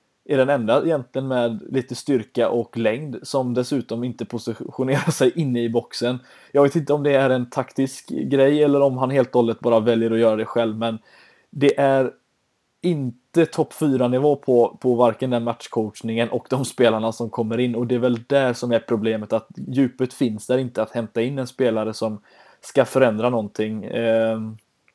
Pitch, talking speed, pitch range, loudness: 125 Hz, 190 wpm, 115-135 Hz, -21 LUFS